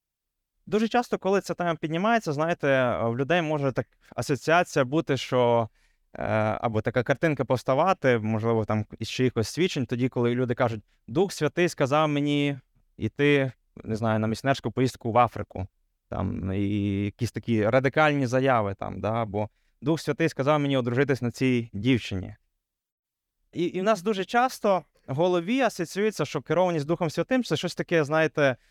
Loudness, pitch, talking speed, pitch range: -26 LUFS, 130 Hz, 155 wpm, 110-160 Hz